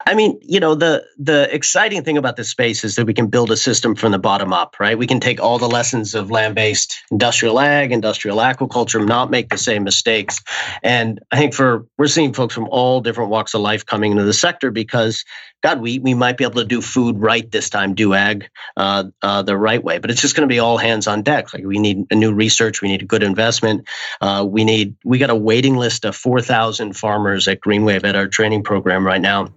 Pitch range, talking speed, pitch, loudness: 105-125 Hz, 240 wpm, 115 Hz, -16 LUFS